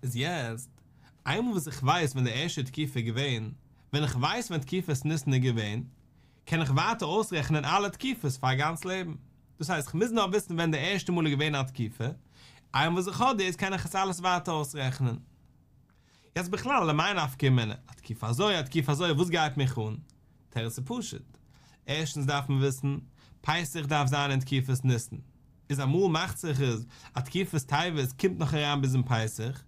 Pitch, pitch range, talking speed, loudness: 145 Hz, 130-165 Hz, 195 wpm, -29 LUFS